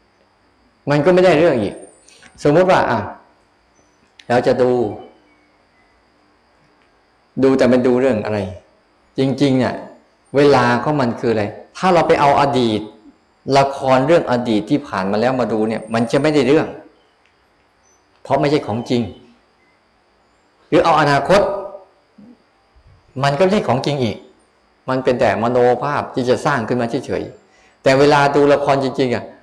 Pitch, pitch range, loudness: 130 Hz, 120-145 Hz, -16 LUFS